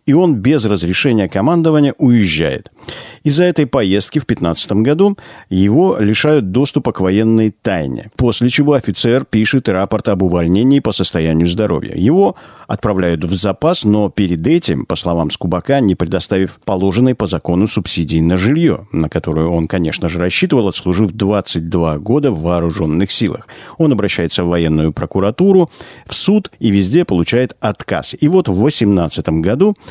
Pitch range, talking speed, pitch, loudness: 90-130 Hz, 150 wpm, 105 Hz, -14 LUFS